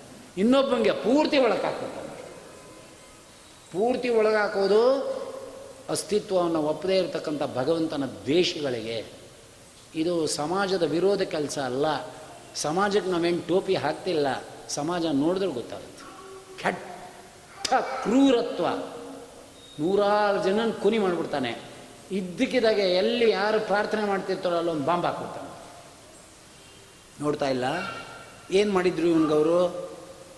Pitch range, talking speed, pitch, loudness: 165-215 Hz, 80 wpm, 190 Hz, -25 LUFS